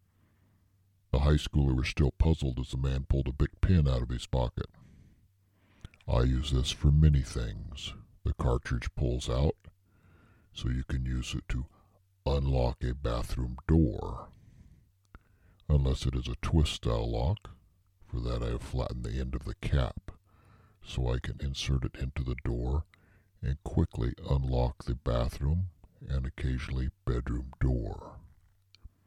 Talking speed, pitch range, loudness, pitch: 145 wpm, 65-95 Hz, -32 LUFS, 75 Hz